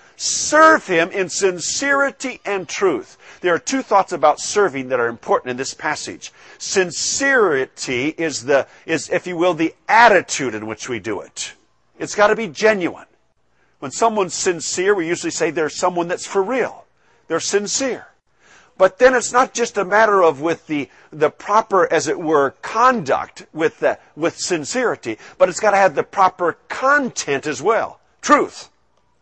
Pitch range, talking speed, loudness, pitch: 165-260 Hz, 165 wpm, -18 LUFS, 200 Hz